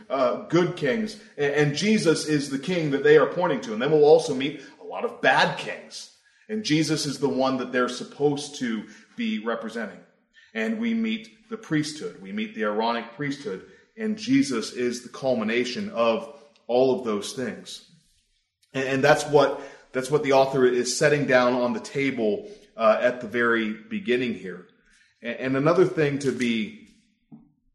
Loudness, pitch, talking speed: -24 LUFS, 145 Hz, 180 wpm